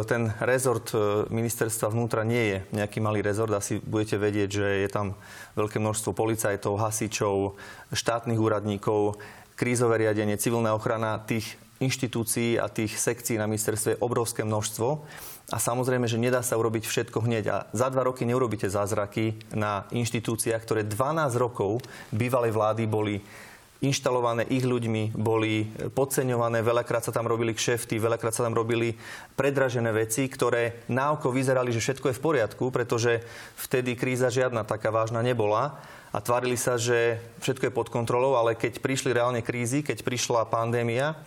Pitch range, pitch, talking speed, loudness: 110-125 Hz, 115 Hz, 155 wpm, -27 LUFS